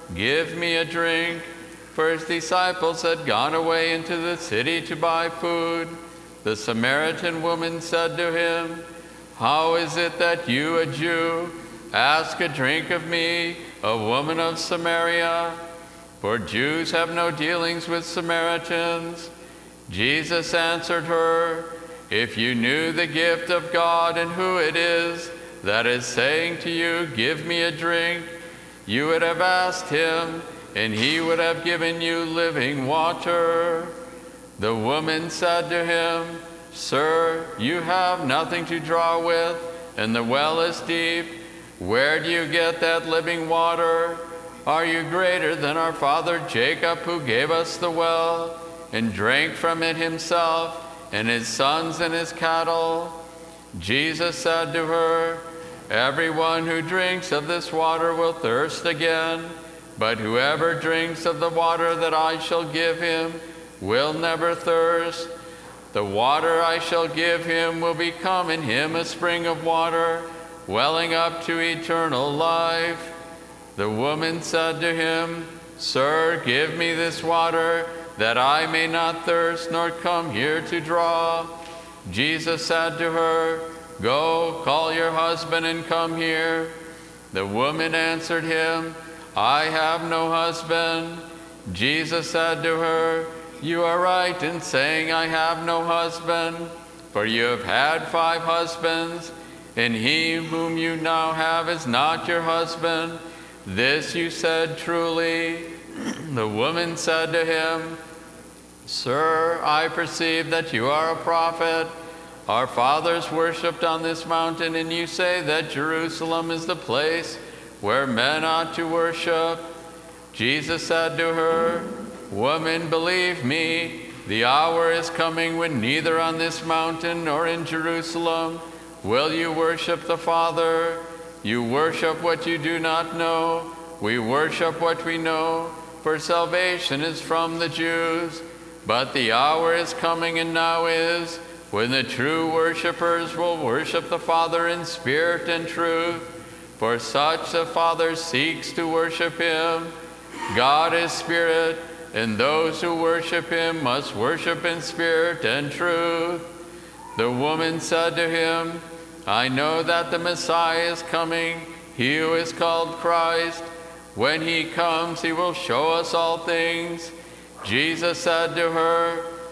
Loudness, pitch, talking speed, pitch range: -22 LUFS, 165 Hz, 140 wpm, 165-170 Hz